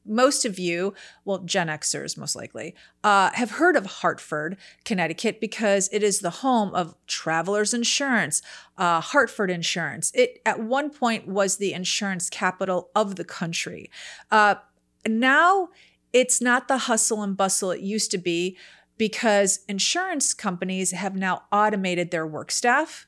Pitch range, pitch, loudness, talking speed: 185-240 Hz, 205 Hz, -23 LUFS, 150 wpm